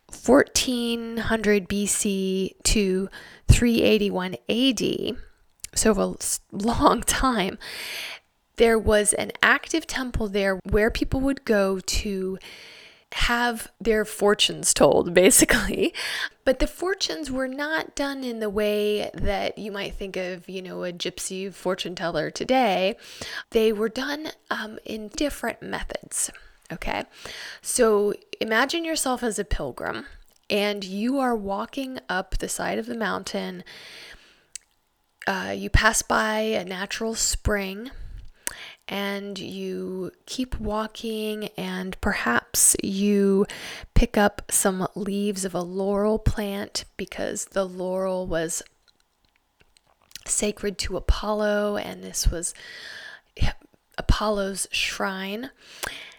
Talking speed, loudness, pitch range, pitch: 110 wpm, -24 LUFS, 195-235 Hz, 210 Hz